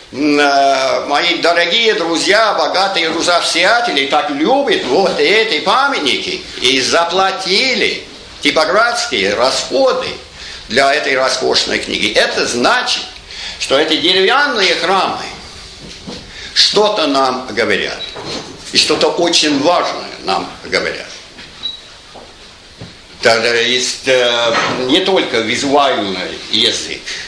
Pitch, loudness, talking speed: 190 Hz, -13 LUFS, 85 wpm